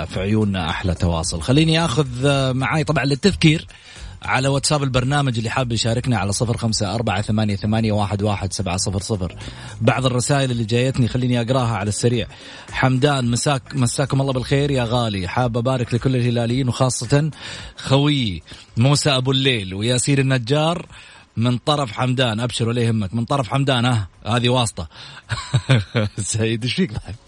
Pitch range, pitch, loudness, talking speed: 110-135 Hz, 125 Hz, -19 LUFS, 140 wpm